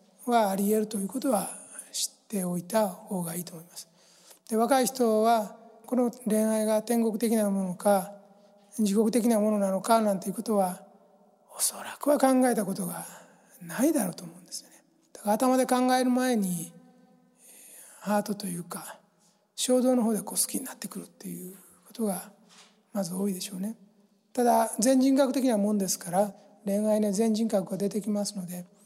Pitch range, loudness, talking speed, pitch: 195-230 Hz, -27 LUFS, 325 characters per minute, 210 Hz